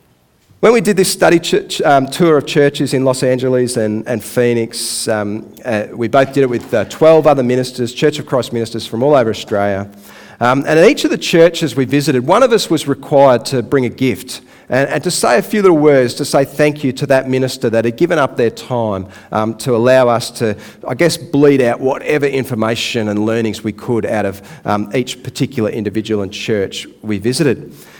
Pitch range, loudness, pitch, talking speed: 115-145 Hz, -14 LUFS, 130 Hz, 210 wpm